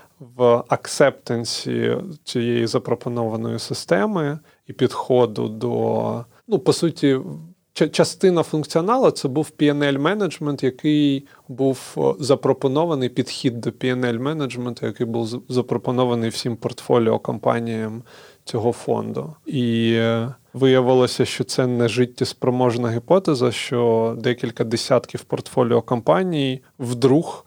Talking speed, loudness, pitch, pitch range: 100 wpm, -21 LUFS, 125 Hz, 120-145 Hz